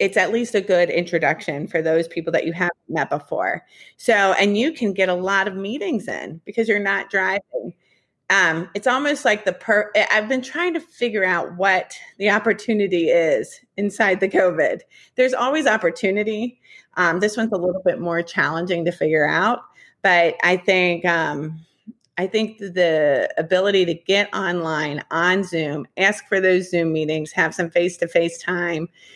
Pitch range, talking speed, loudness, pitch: 170-210 Hz, 175 wpm, -20 LUFS, 190 Hz